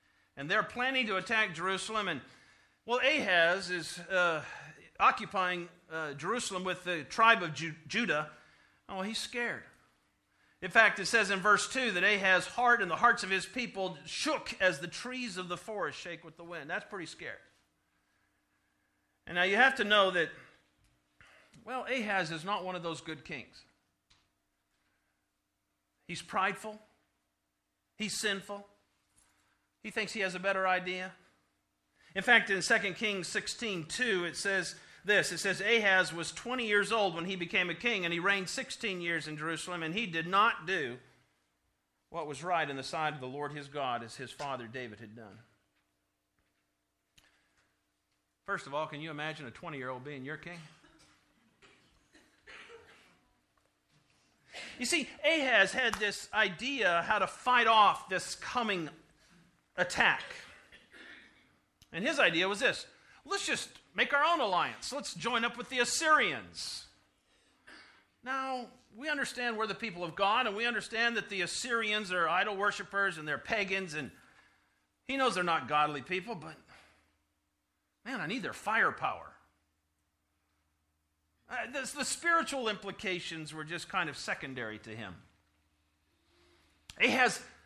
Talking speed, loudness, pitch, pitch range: 150 wpm, -31 LUFS, 185 Hz, 145-220 Hz